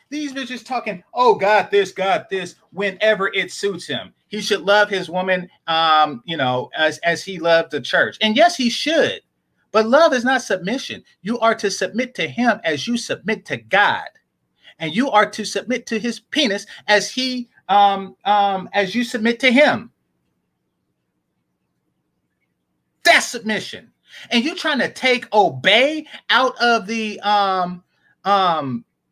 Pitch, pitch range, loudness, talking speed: 205 Hz, 175-235 Hz, -18 LUFS, 155 wpm